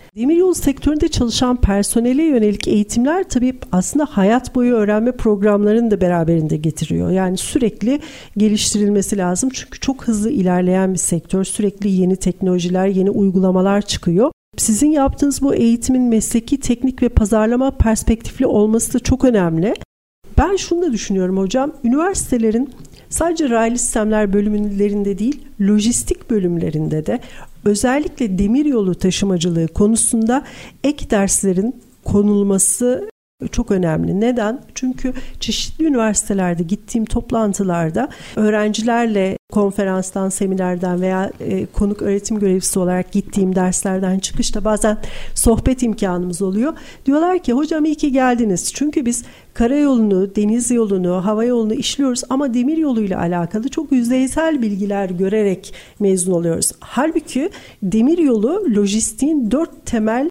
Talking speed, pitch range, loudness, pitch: 120 wpm, 195-255 Hz, -17 LUFS, 220 Hz